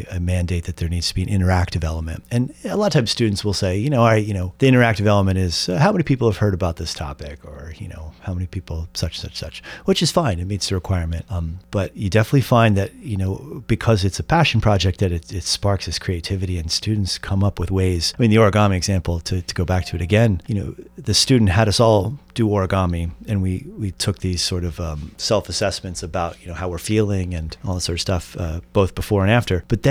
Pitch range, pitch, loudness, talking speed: 90-110 Hz, 95 Hz, -20 LUFS, 255 wpm